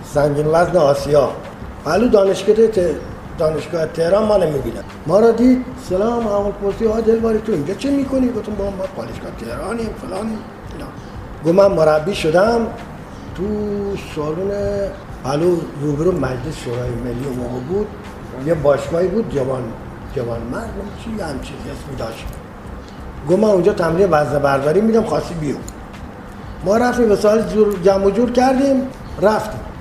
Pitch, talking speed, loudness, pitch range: 185 Hz, 145 wpm, -17 LUFS, 145-210 Hz